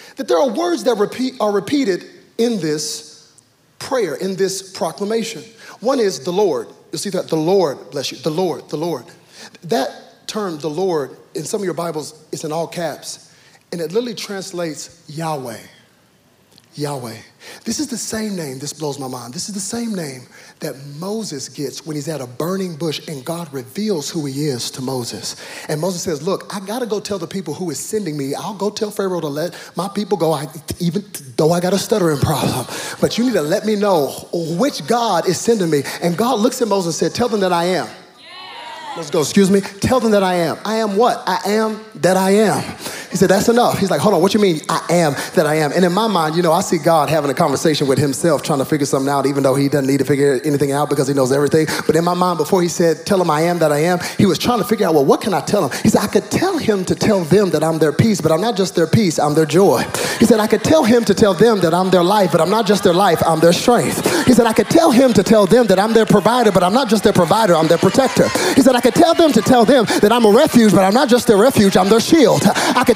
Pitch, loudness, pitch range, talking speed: 185 Hz, -16 LUFS, 155-220 Hz, 260 wpm